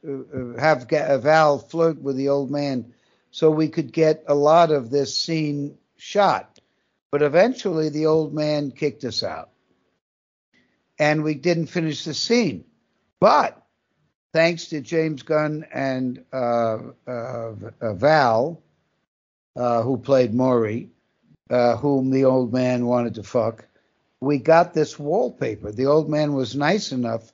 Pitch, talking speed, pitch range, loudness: 140 Hz, 135 wpm, 125-155 Hz, -21 LUFS